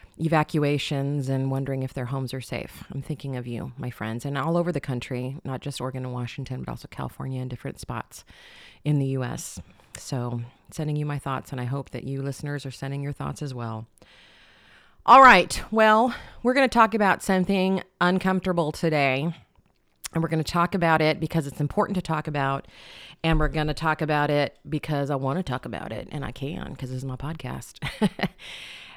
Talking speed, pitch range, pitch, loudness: 200 wpm, 130-160 Hz, 145 Hz, -25 LUFS